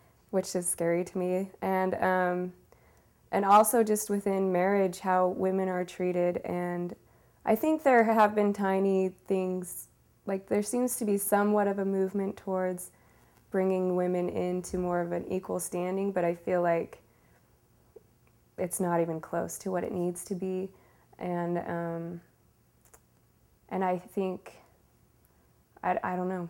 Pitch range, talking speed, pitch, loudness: 180-195 Hz, 145 wpm, 185 Hz, -29 LUFS